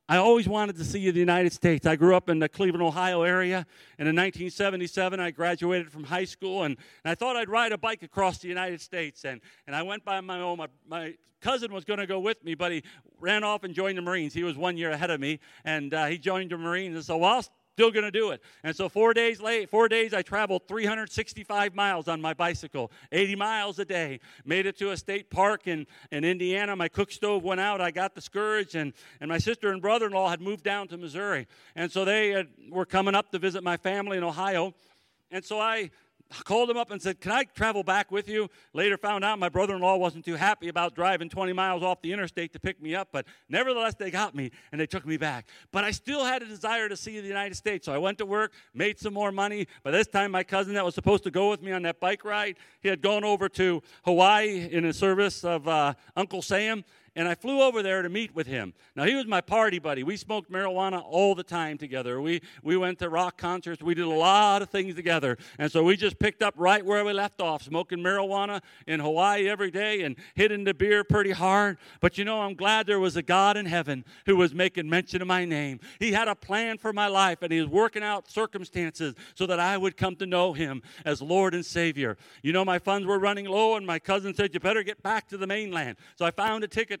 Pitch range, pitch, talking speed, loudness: 170-205 Hz, 190 Hz, 245 wpm, -27 LUFS